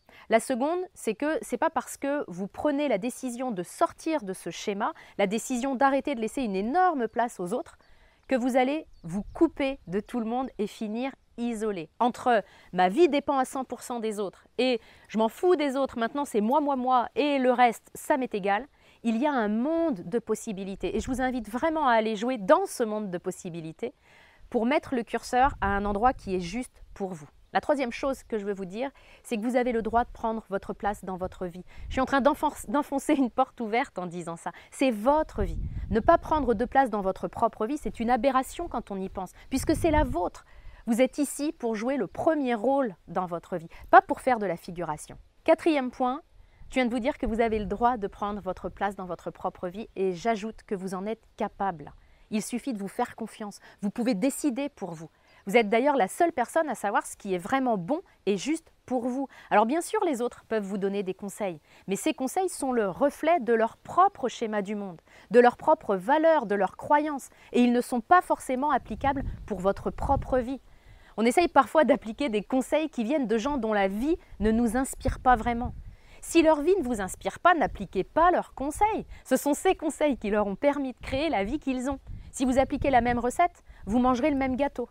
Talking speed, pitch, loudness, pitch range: 225 wpm, 245 Hz, -27 LUFS, 210-280 Hz